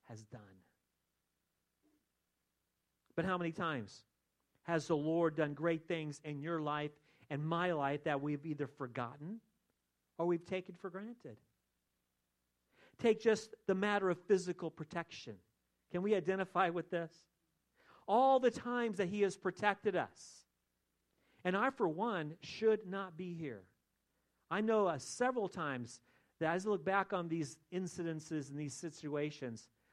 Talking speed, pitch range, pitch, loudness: 140 wpm, 135-190 Hz, 165 Hz, -38 LUFS